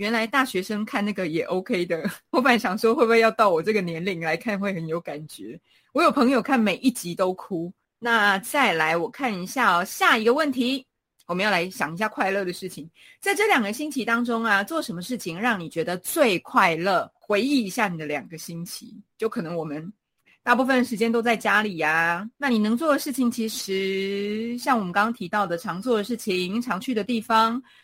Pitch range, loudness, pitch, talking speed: 185-245 Hz, -23 LUFS, 215 Hz, 310 characters per minute